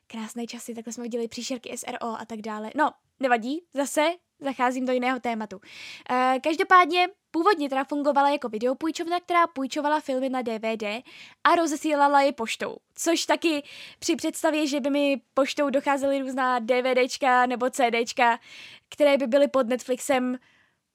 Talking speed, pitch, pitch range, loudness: 145 wpm, 270 Hz, 245-300 Hz, -25 LUFS